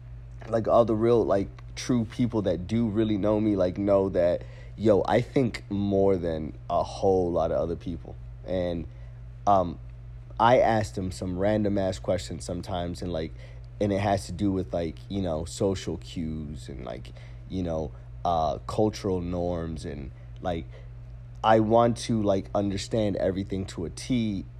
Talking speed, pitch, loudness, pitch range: 165 wpm, 95 Hz, -27 LUFS, 75-105 Hz